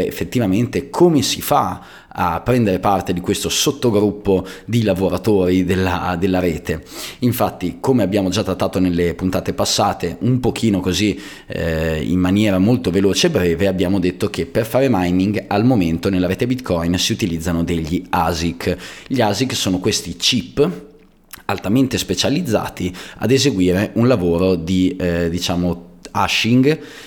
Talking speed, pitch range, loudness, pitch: 140 wpm, 90-105 Hz, -18 LUFS, 95 Hz